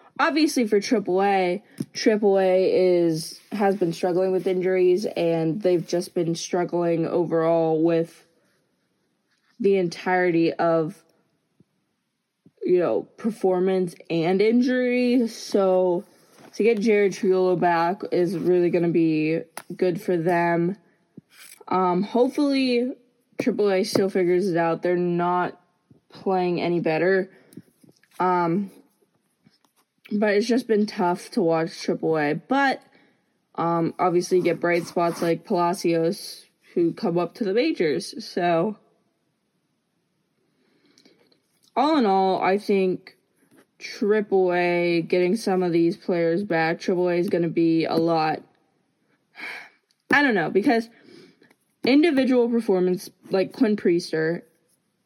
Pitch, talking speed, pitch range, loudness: 180 Hz, 115 wpm, 170-210 Hz, -22 LUFS